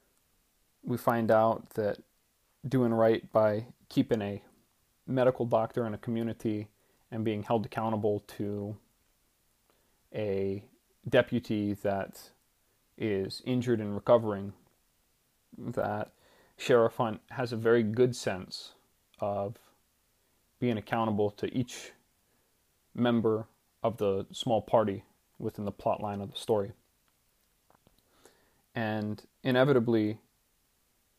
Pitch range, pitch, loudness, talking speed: 100-120 Hz, 110 Hz, -31 LUFS, 100 wpm